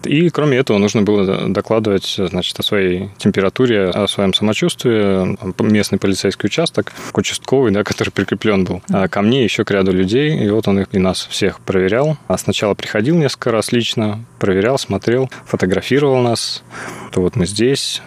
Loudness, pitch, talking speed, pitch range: -16 LUFS, 105 Hz, 165 wpm, 95-120 Hz